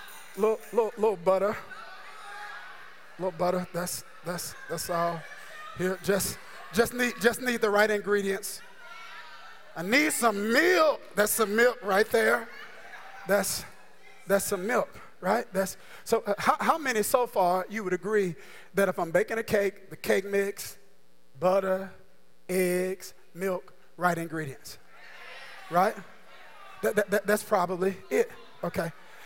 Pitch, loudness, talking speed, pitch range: 200 Hz, -28 LUFS, 135 wpm, 185-225 Hz